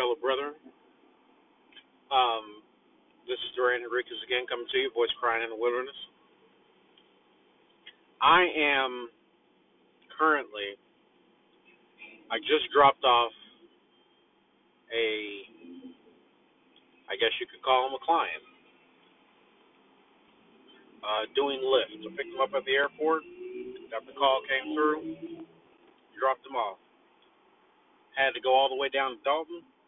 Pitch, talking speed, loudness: 135 Hz, 120 wpm, -28 LUFS